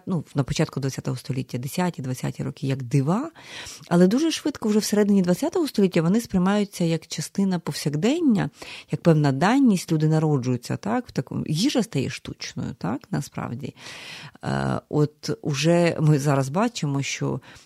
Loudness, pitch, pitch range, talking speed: -23 LUFS, 165 Hz, 140-200 Hz, 140 wpm